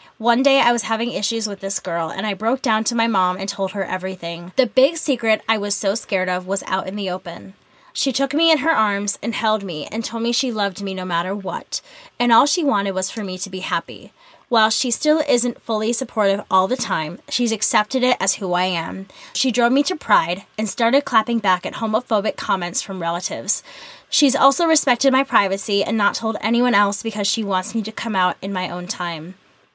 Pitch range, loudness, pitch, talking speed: 190-245 Hz, -19 LUFS, 215 Hz, 225 wpm